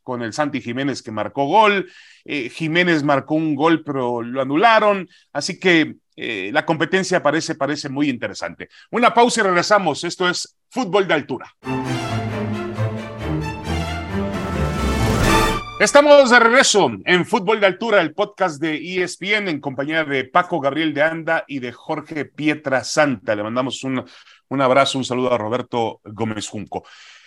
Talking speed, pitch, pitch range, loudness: 145 wpm, 145 Hz, 120-175 Hz, -19 LUFS